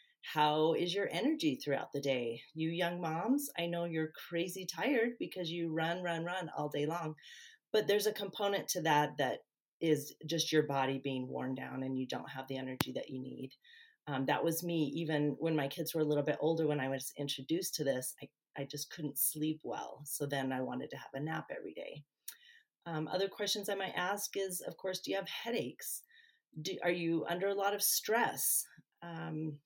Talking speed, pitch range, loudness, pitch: 210 wpm, 145-195 Hz, -36 LUFS, 165 Hz